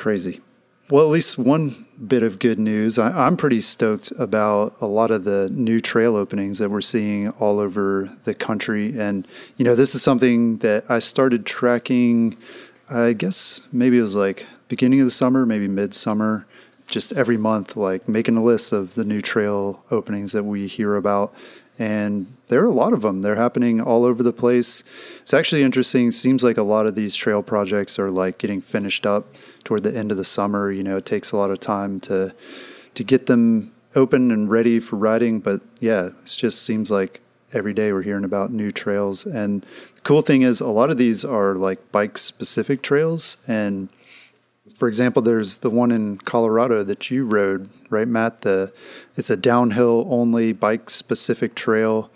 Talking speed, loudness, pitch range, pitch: 190 wpm, -20 LUFS, 100-120 Hz, 110 Hz